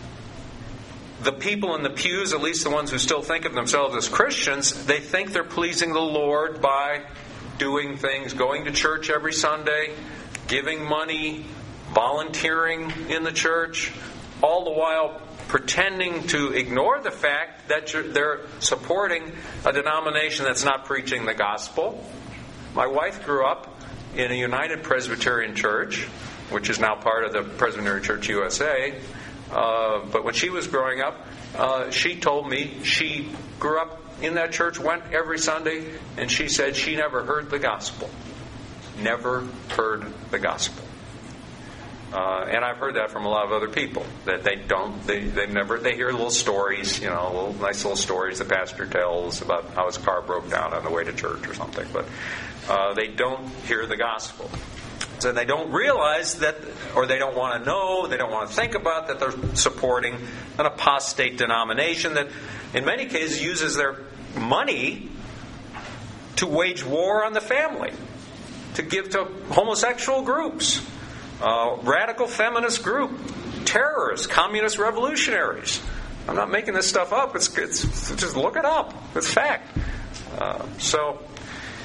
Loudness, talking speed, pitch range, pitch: -24 LUFS, 160 wpm, 120-160 Hz, 140 Hz